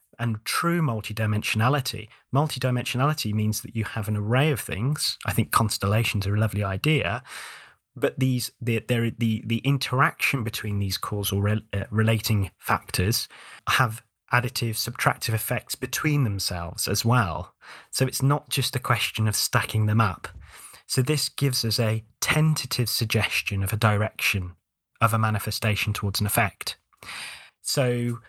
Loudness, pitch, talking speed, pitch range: -25 LUFS, 115 Hz, 145 wpm, 105-125 Hz